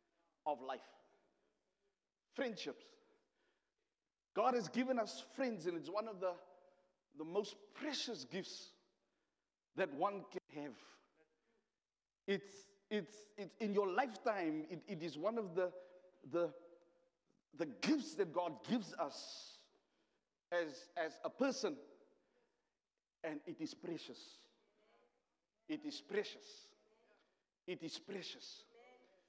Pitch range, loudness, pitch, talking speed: 180-240 Hz, -43 LUFS, 205 Hz, 110 wpm